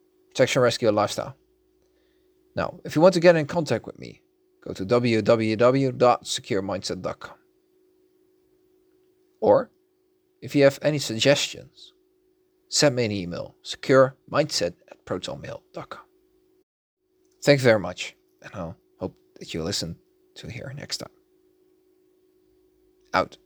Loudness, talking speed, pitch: -23 LUFS, 115 wpm, 360 Hz